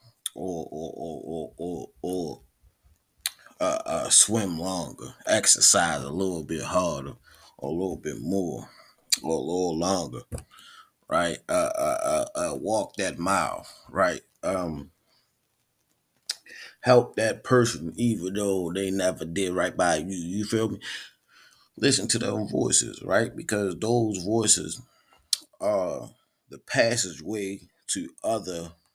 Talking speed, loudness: 125 wpm, -26 LUFS